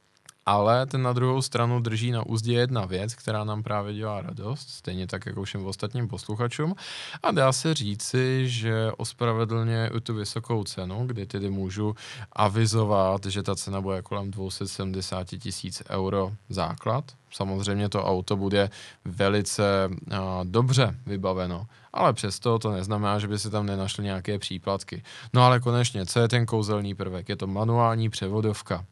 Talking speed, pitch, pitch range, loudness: 155 wpm, 105 Hz, 100-115 Hz, -27 LUFS